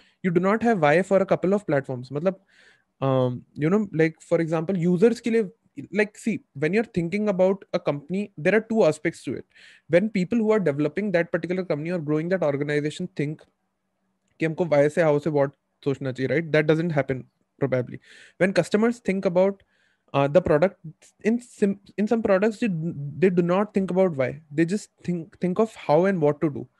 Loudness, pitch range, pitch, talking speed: -24 LUFS, 150-200 Hz, 180 Hz, 195 wpm